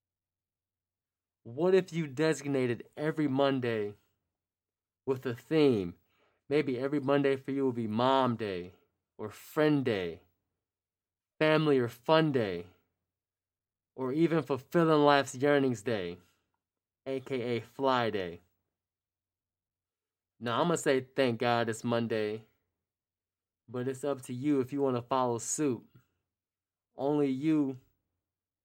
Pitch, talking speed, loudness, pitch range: 115 Hz, 115 wpm, -30 LUFS, 95-135 Hz